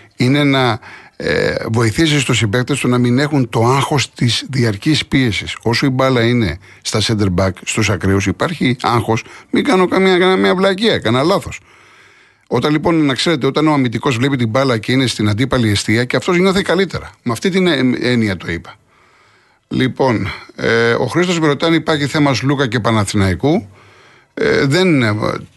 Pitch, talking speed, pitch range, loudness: 130 Hz, 160 wpm, 115-155 Hz, -15 LUFS